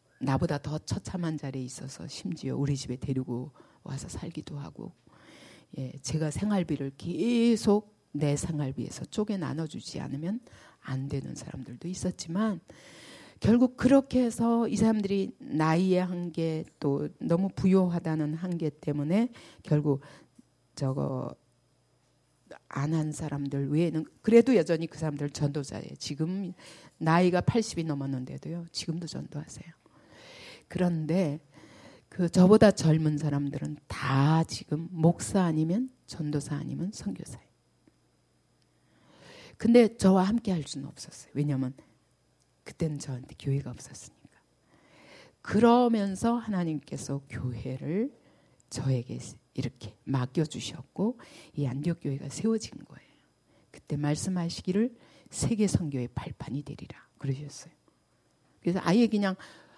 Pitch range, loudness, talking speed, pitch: 140-185 Hz, -29 LUFS, 275 characters per minute, 155 Hz